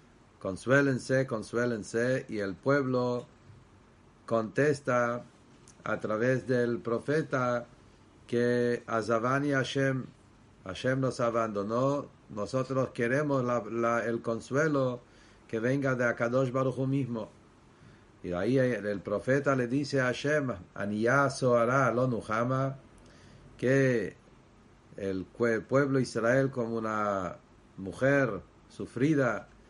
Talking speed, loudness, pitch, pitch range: 105 wpm, -30 LUFS, 120 Hz, 110-130 Hz